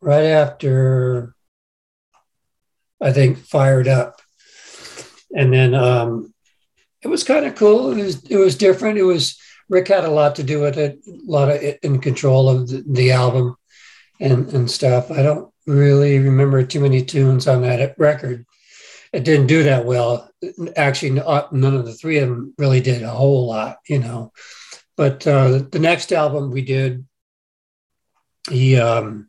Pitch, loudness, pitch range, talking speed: 135 Hz, -16 LUFS, 125-150 Hz, 165 wpm